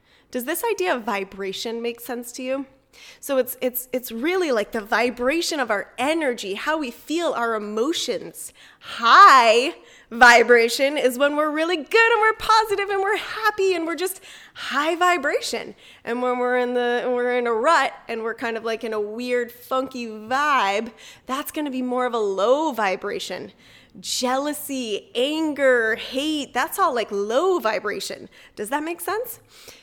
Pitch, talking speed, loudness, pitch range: 260 Hz, 165 wpm, -21 LUFS, 235-335 Hz